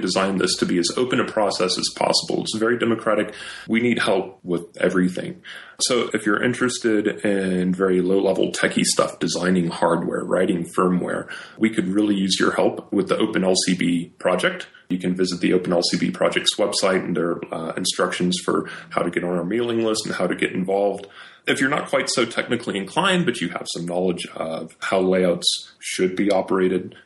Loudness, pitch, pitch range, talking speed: -21 LUFS, 95 Hz, 90-105 Hz, 185 wpm